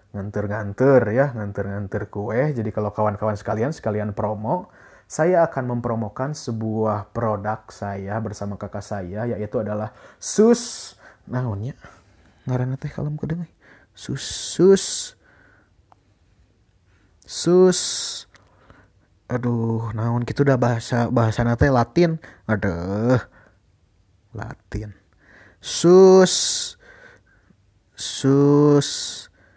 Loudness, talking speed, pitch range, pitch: -21 LUFS, 85 wpm, 100-135 Hz, 110 Hz